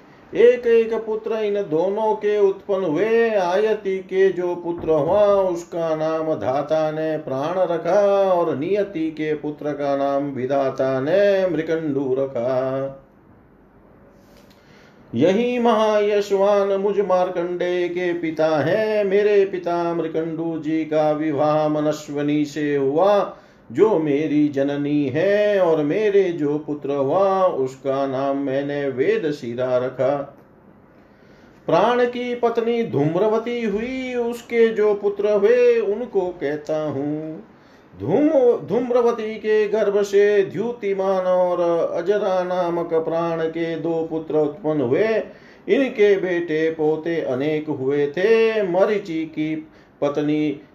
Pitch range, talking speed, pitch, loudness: 150-205 Hz, 115 wpm, 170 Hz, -20 LUFS